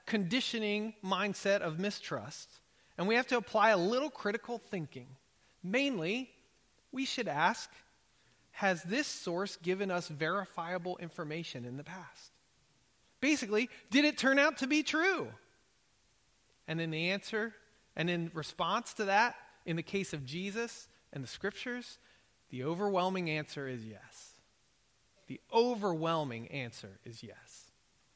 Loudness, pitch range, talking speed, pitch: -34 LUFS, 160-235 Hz, 130 wpm, 195 Hz